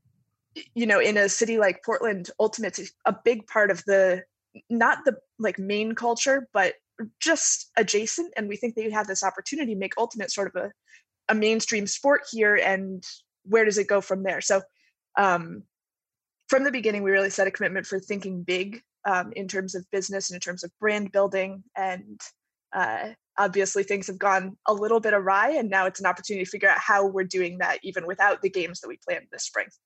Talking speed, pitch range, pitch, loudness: 200 wpm, 190-225 Hz, 200 Hz, -25 LUFS